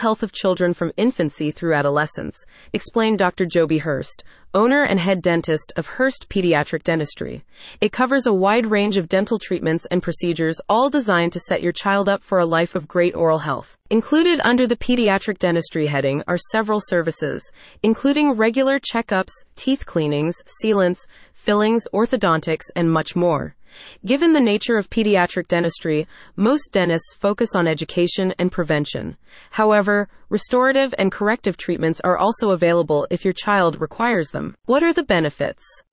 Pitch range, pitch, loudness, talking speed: 170-220 Hz, 190 Hz, -19 LUFS, 155 wpm